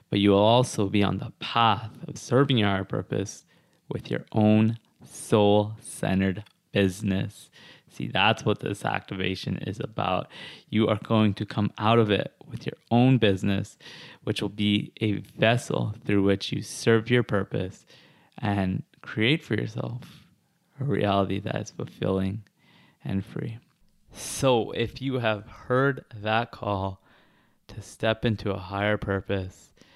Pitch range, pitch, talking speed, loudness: 100-115 Hz, 105 Hz, 145 wpm, -26 LUFS